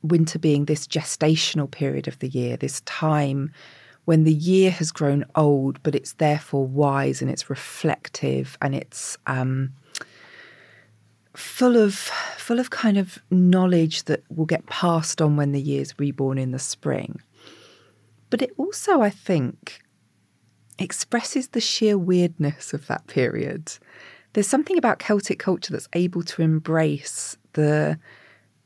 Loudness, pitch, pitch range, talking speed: -23 LUFS, 155 Hz, 140-185 Hz, 140 wpm